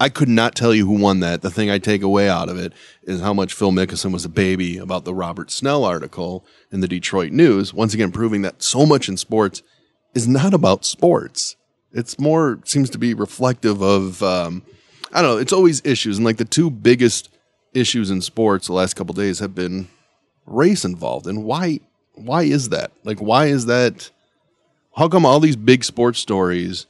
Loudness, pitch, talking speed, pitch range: -18 LUFS, 105 Hz, 205 wpm, 95-125 Hz